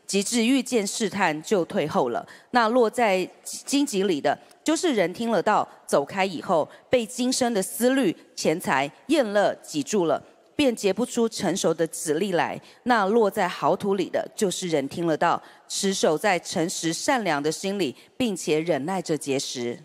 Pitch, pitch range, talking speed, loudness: 200 Hz, 170-245 Hz, 240 characters per minute, -24 LUFS